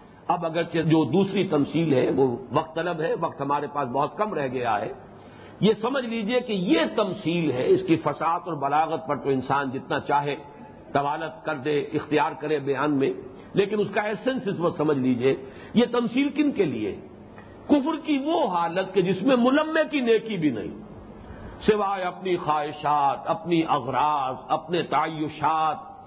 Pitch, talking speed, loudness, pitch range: 165 Hz, 170 wpm, -25 LUFS, 145-210 Hz